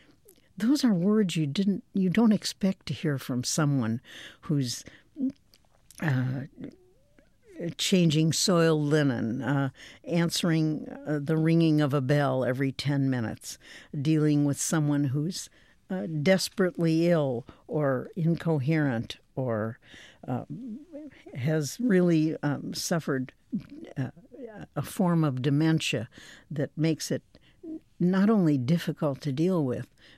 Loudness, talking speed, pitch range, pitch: -27 LUFS, 115 wpm, 140-180 Hz, 155 Hz